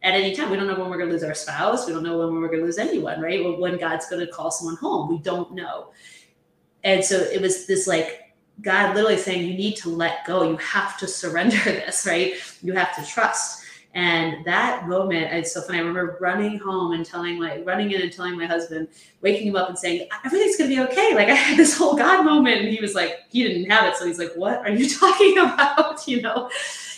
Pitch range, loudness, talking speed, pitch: 170-215 Hz, -21 LUFS, 250 wpm, 185 Hz